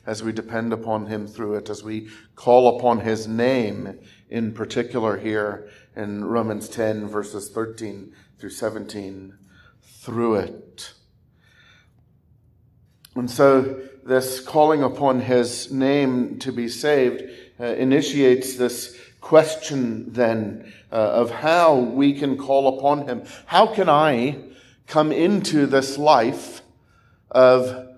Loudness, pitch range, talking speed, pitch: -21 LUFS, 110-135 Hz, 115 wpm, 125 Hz